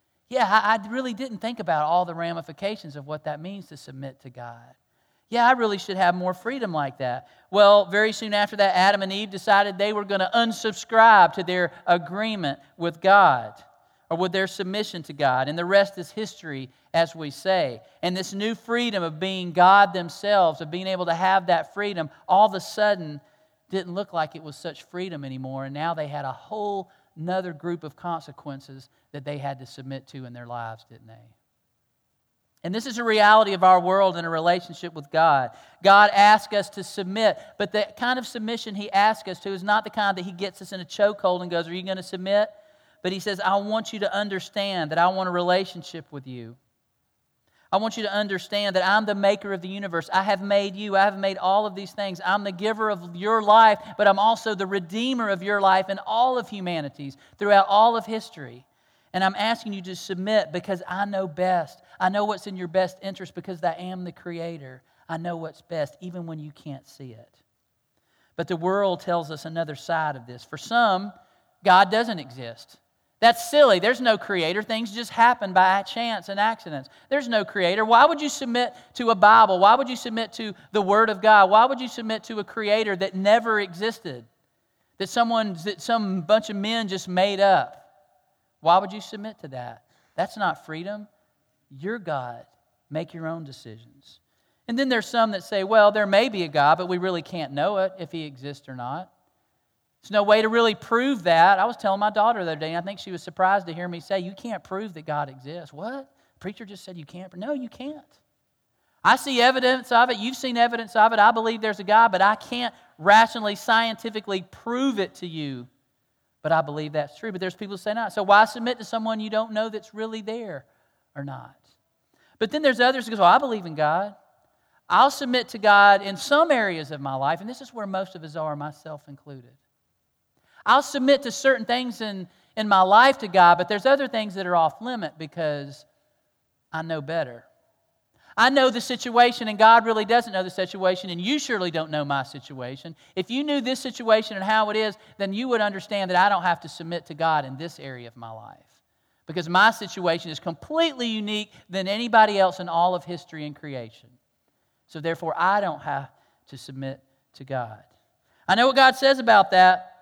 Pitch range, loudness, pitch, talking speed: 165-220 Hz, -22 LUFS, 195 Hz, 210 wpm